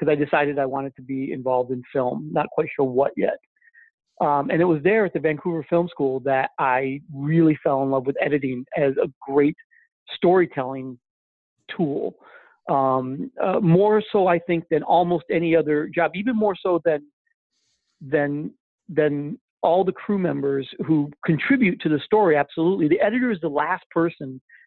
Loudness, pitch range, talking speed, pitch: -22 LUFS, 140-180 Hz, 175 wpm, 155 Hz